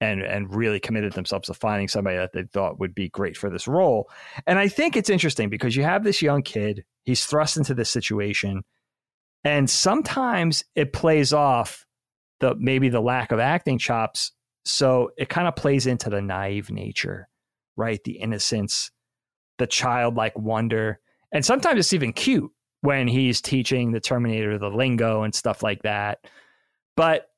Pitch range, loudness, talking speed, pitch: 105-140 Hz, -23 LUFS, 170 wpm, 120 Hz